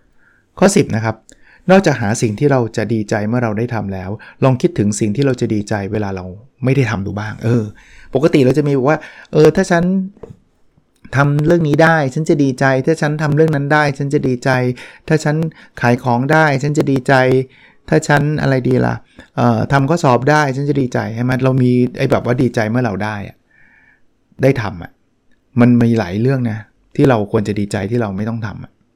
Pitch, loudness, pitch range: 130 Hz, -15 LUFS, 110-150 Hz